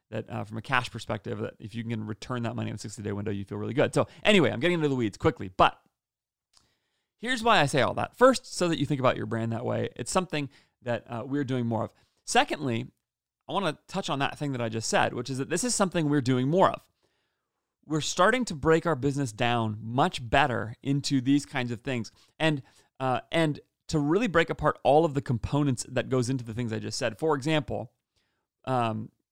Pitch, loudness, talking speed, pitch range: 130 Hz, -28 LUFS, 230 wpm, 115-150 Hz